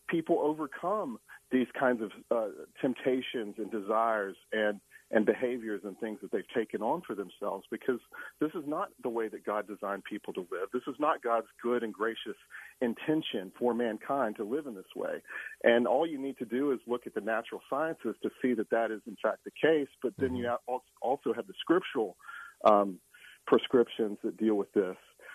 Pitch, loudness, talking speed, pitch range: 120 Hz, -32 LUFS, 190 wpm, 110-135 Hz